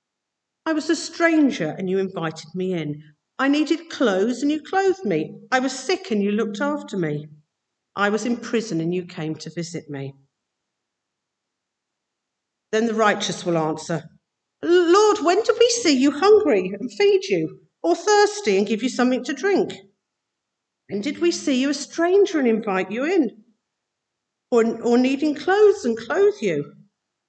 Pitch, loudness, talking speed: 235 Hz, -21 LUFS, 165 wpm